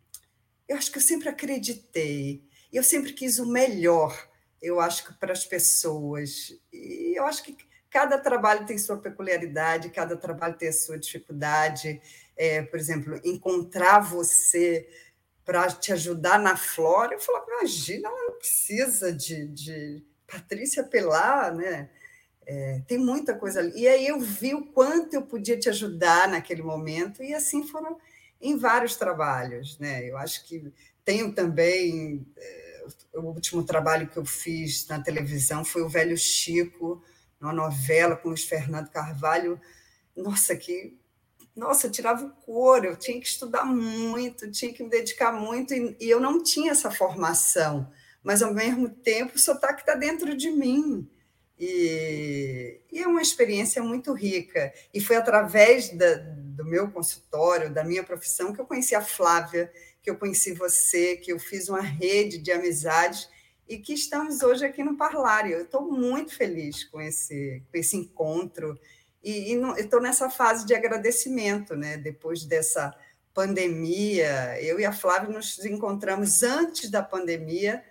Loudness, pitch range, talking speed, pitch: -25 LUFS, 165-250 Hz, 155 wpm, 190 Hz